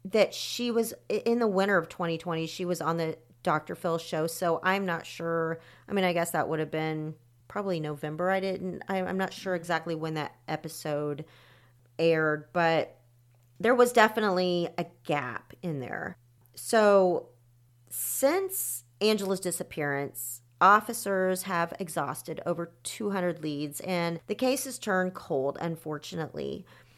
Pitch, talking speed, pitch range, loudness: 165 Hz, 140 wpm, 150-190 Hz, -29 LUFS